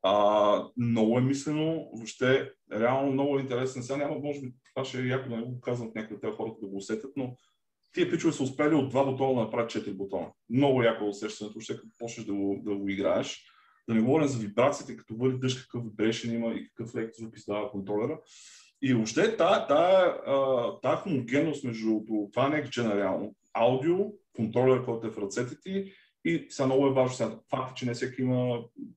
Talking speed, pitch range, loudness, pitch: 200 wpm, 110-135 Hz, -29 LUFS, 125 Hz